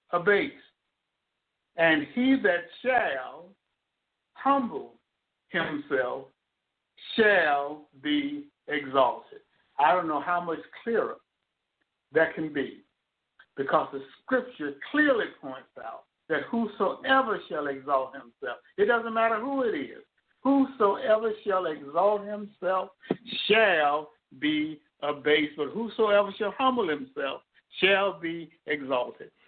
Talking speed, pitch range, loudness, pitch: 105 wpm, 150-235 Hz, -27 LUFS, 195 Hz